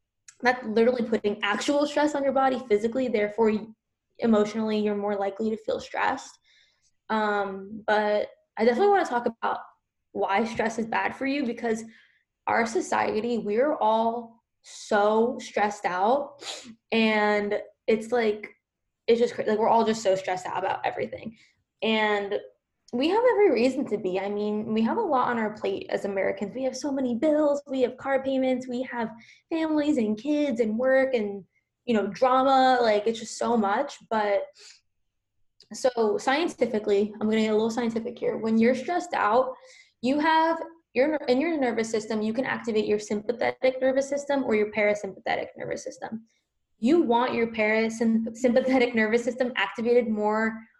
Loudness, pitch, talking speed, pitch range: -26 LUFS, 230 Hz, 165 wpm, 215-265 Hz